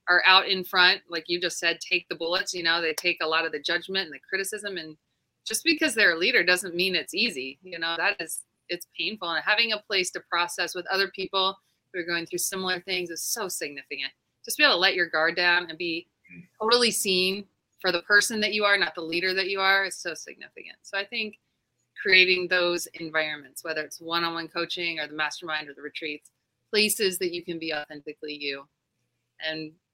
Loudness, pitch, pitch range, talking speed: -25 LUFS, 175 Hz, 160-190 Hz, 215 wpm